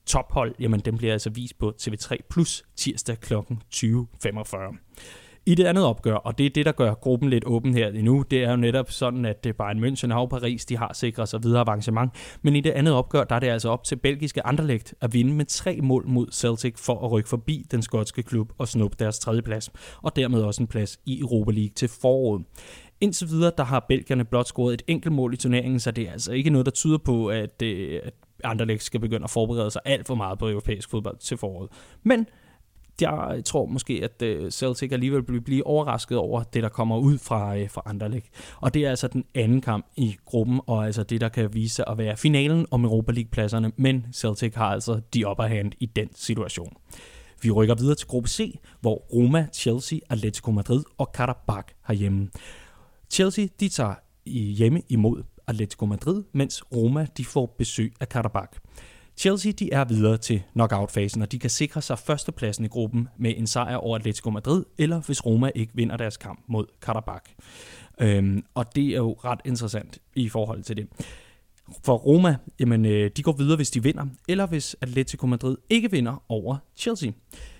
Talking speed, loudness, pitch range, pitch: 200 wpm, -25 LUFS, 110-135 Hz, 120 Hz